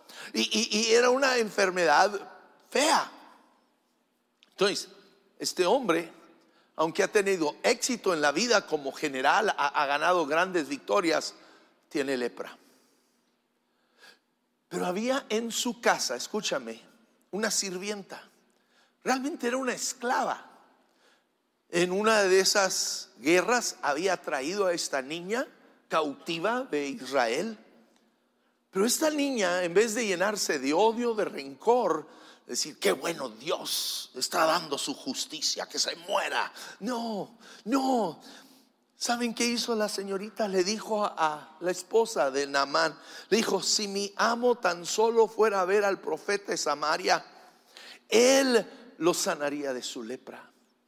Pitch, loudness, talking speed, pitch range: 205 Hz, -27 LUFS, 125 wpm, 175-235 Hz